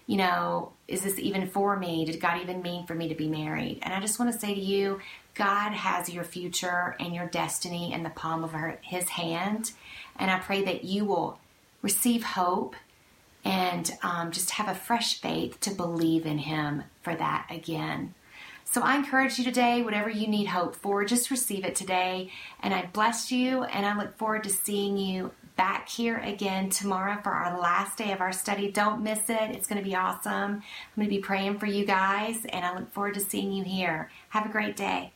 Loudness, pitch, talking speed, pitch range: -29 LUFS, 195 Hz, 210 wpm, 175-210 Hz